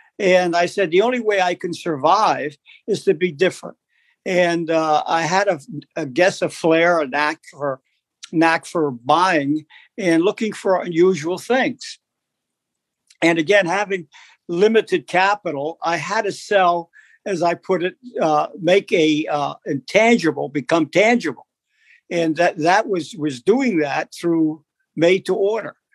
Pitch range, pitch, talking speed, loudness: 160-195 Hz, 175 Hz, 150 wpm, -19 LUFS